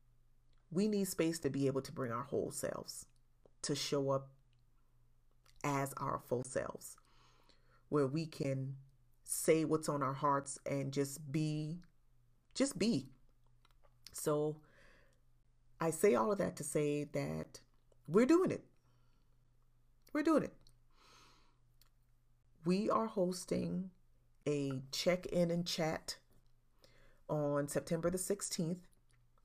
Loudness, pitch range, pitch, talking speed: -37 LUFS, 120-160 Hz, 135 Hz, 120 wpm